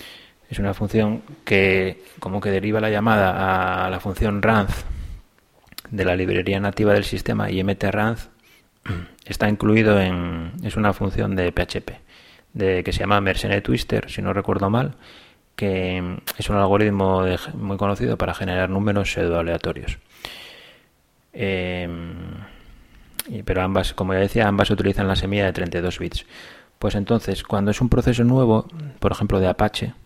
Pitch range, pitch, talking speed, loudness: 95-105 Hz, 100 Hz, 150 wpm, -21 LUFS